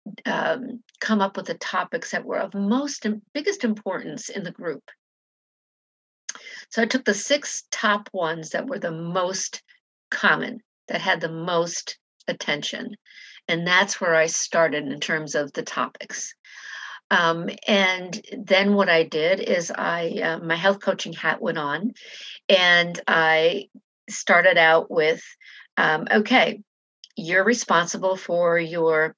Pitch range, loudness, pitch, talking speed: 165-220 Hz, -22 LUFS, 190 Hz, 140 wpm